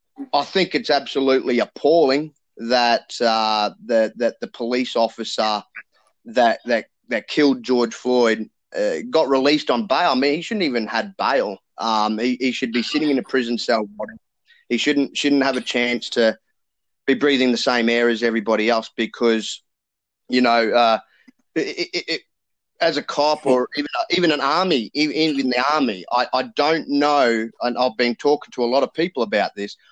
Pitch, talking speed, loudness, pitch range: 125 Hz, 180 wpm, -20 LUFS, 115-145 Hz